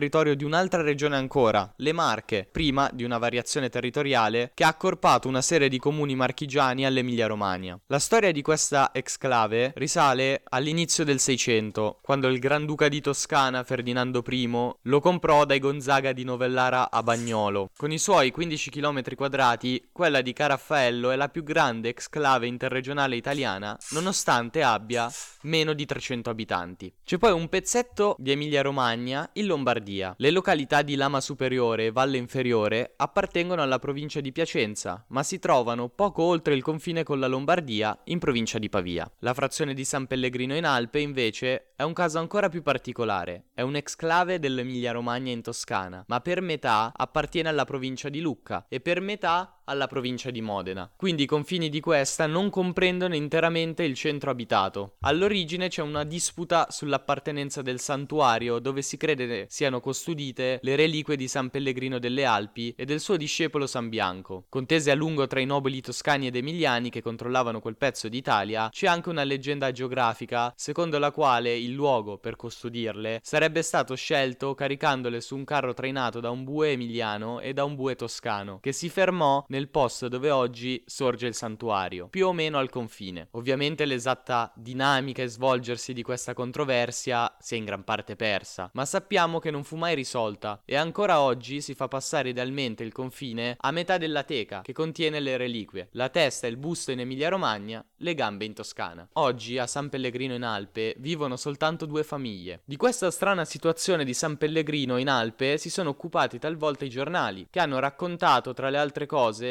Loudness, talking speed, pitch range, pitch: -26 LUFS, 170 wpm, 120-150 Hz, 135 Hz